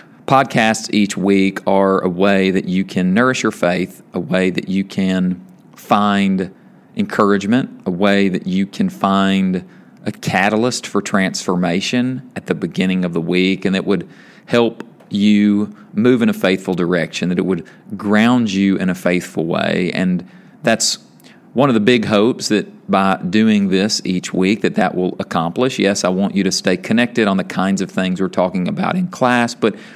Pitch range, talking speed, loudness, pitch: 95-110 Hz, 180 wpm, -16 LUFS, 95 Hz